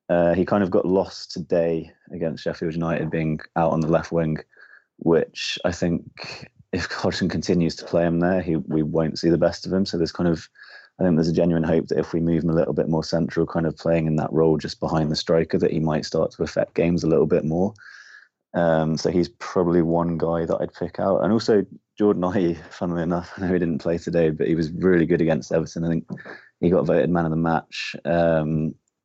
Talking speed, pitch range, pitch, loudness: 235 wpm, 80-85 Hz, 85 Hz, -22 LUFS